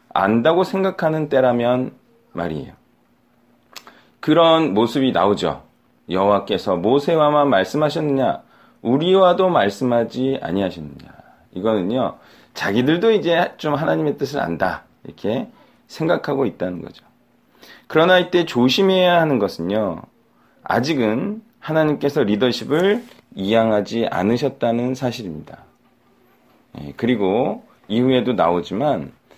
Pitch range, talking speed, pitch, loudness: 100-160 Hz, 270 characters per minute, 130 Hz, -19 LUFS